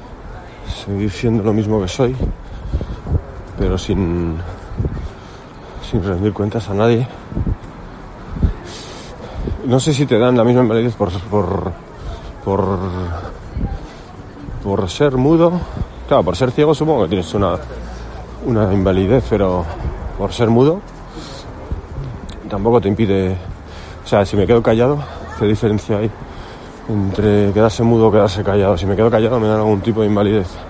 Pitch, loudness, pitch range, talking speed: 105 Hz, -17 LUFS, 95-115 Hz, 135 wpm